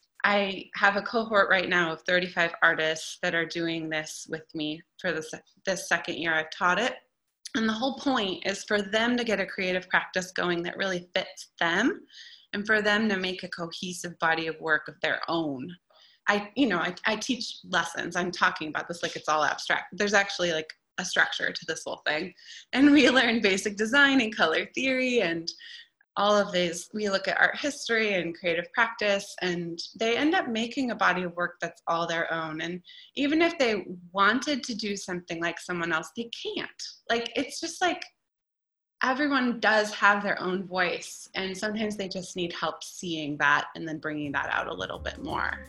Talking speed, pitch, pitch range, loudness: 200 wpm, 190 Hz, 170-225 Hz, -27 LUFS